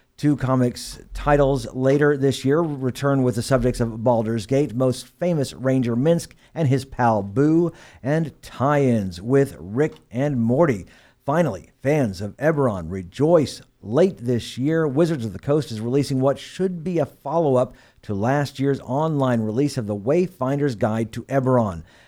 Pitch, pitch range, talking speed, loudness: 130 Hz, 120-145 Hz, 160 wpm, -22 LUFS